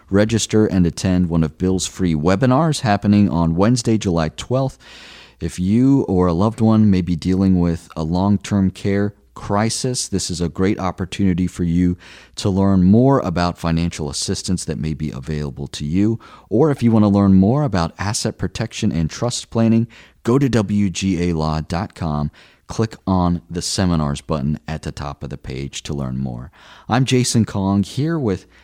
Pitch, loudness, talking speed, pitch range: 95 Hz, -18 LUFS, 170 wpm, 85-110 Hz